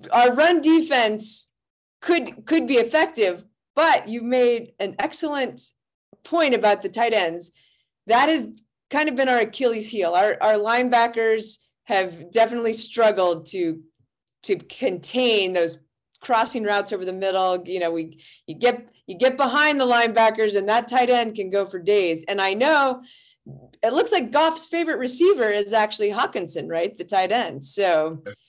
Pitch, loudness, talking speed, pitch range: 225 Hz, -21 LUFS, 160 wpm, 195-260 Hz